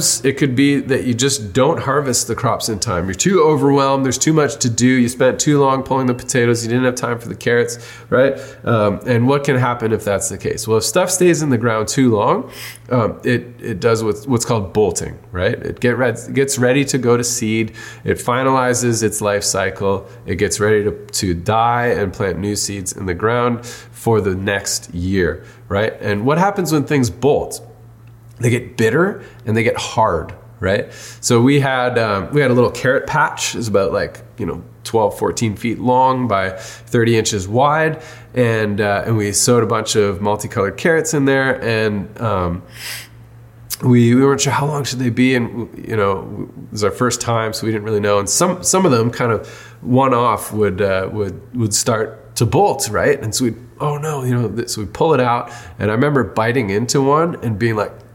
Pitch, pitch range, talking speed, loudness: 120 Hz, 110-130 Hz, 215 wpm, -17 LUFS